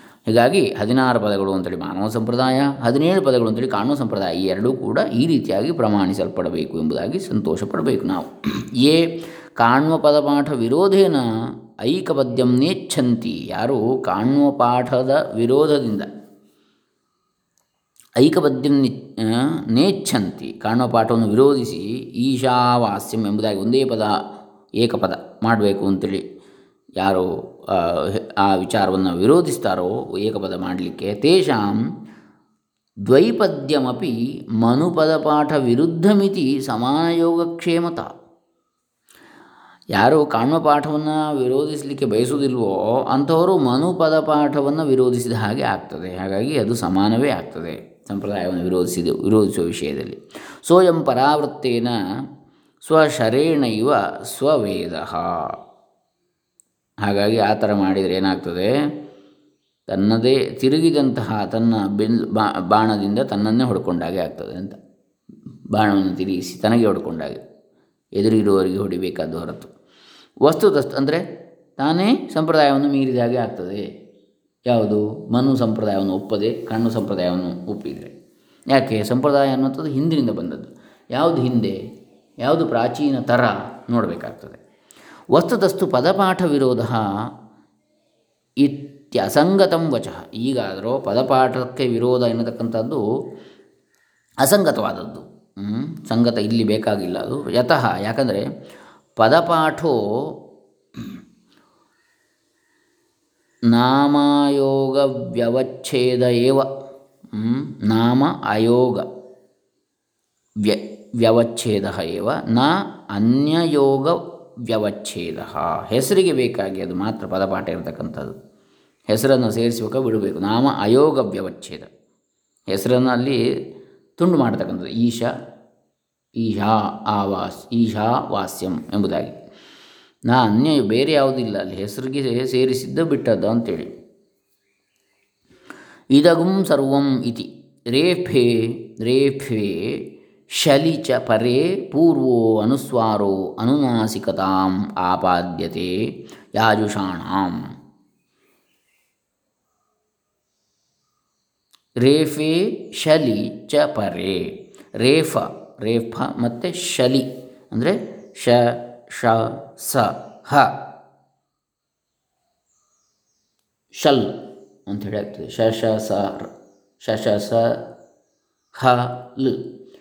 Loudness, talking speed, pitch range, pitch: -19 LUFS, 75 wpm, 105-145 Hz, 125 Hz